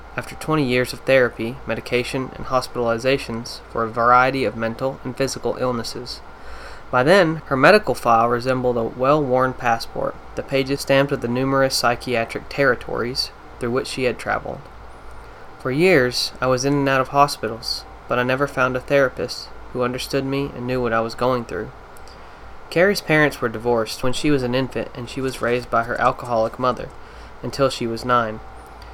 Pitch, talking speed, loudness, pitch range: 125 Hz, 175 wpm, -20 LUFS, 120-135 Hz